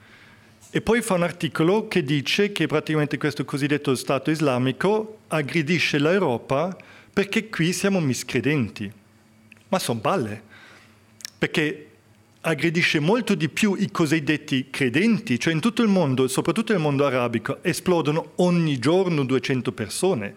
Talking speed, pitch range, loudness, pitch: 130 wpm, 130-180 Hz, -23 LUFS, 155 Hz